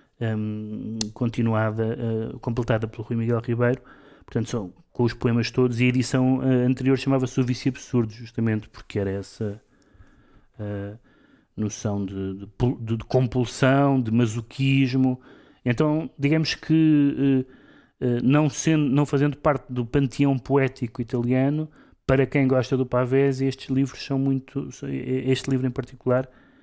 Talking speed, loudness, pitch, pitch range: 125 wpm, -24 LUFS, 130 Hz, 115-135 Hz